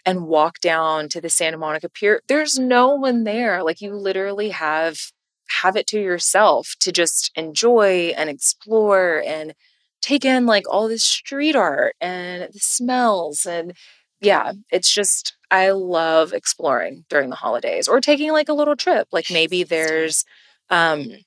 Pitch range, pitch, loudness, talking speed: 165-250 Hz, 195 Hz, -18 LUFS, 160 wpm